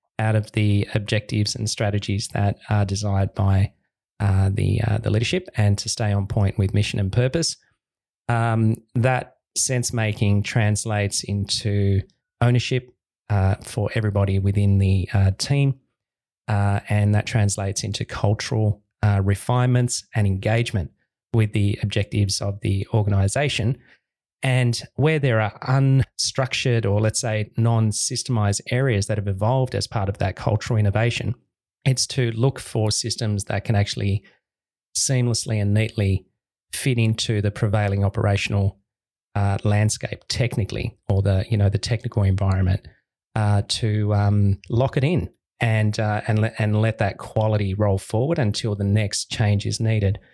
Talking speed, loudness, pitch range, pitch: 145 wpm, -22 LUFS, 100-120 Hz, 110 Hz